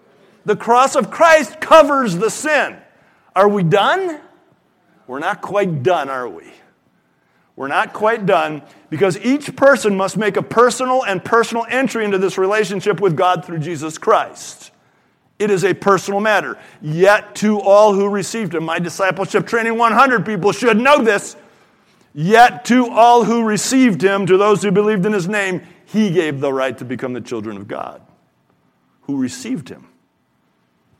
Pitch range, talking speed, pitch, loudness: 180-230 Hz, 160 wpm, 205 Hz, -15 LUFS